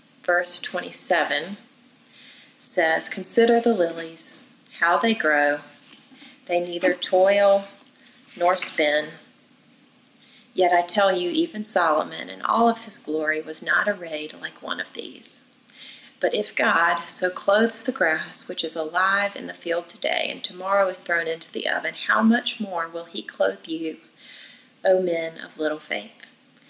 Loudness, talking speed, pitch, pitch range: -23 LUFS, 145 wpm, 195 Hz, 170-255 Hz